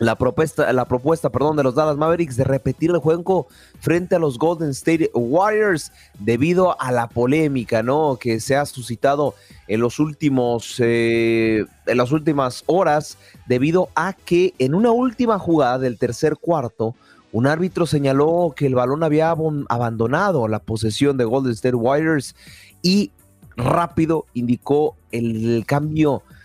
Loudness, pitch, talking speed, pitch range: -19 LUFS, 140 Hz, 145 wpm, 120-160 Hz